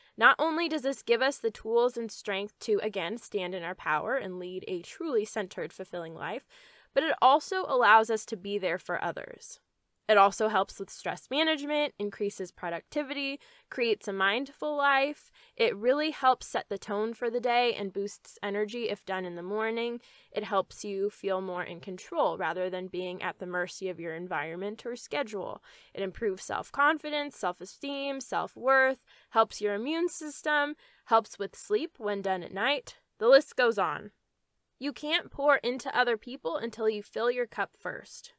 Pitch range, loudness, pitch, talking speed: 195-285 Hz, -30 LUFS, 225 Hz, 180 wpm